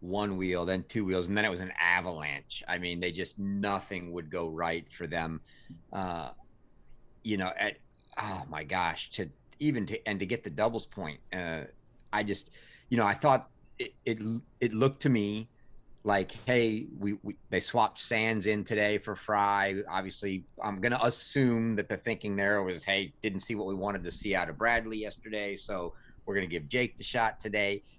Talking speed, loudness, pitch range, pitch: 195 wpm, -32 LUFS, 95-110 Hz, 100 Hz